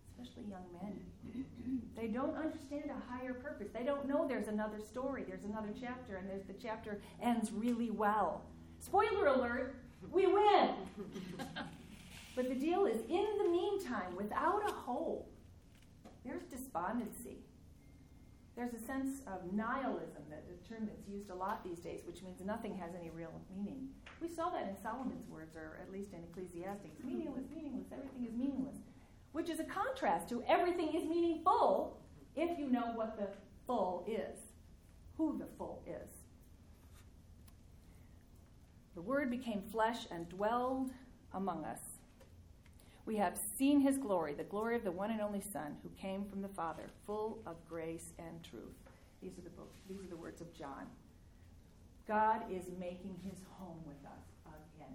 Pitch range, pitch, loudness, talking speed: 185-265 Hz, 220 Hz, -40 LUFS, 160 wpm